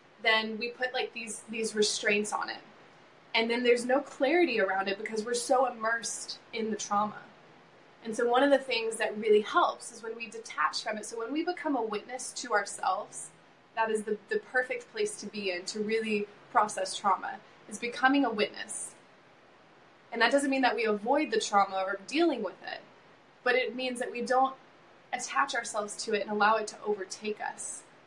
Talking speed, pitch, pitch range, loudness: 195 wpm, 225 Hz, 210-250 Hz, -30 LUFS